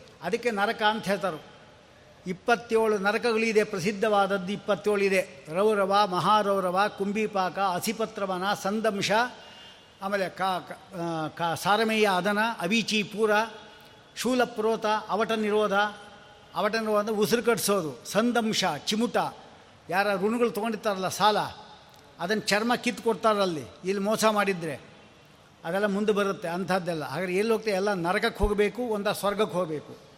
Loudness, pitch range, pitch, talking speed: -26 LUFS, 190-215 Hz, 205 Hz, 100 wpm